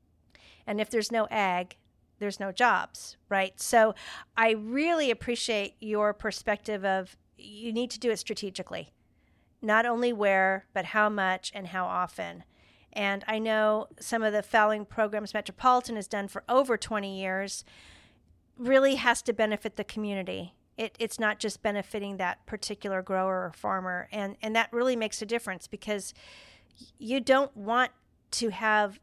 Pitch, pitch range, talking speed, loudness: 210 Hz, 195-225 Hz, 155 wpm, -29 LUFS